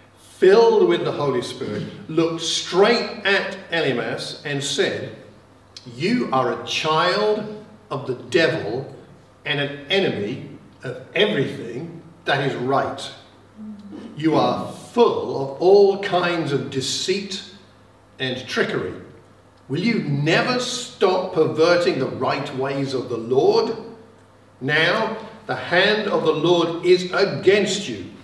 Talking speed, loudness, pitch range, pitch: 120 wpm, -20 LUFS, 130-200 Hz, 165 Hz